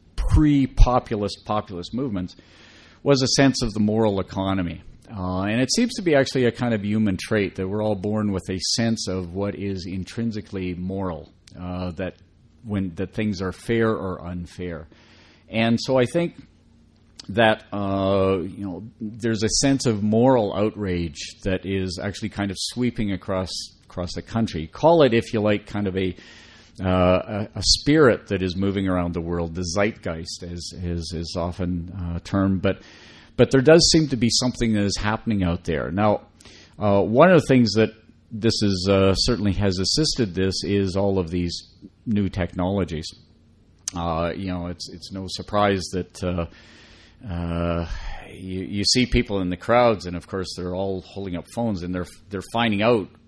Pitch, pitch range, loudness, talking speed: 100 Hz, 90-110 Hz, -22 LUFS, 175 wpm